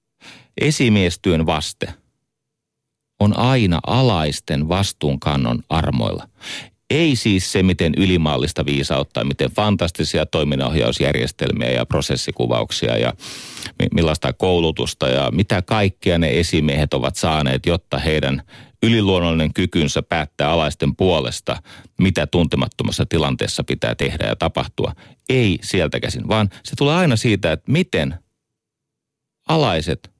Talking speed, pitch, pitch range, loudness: 105 wpm, 85 Hz, 75-105 Hz, -19 LUFS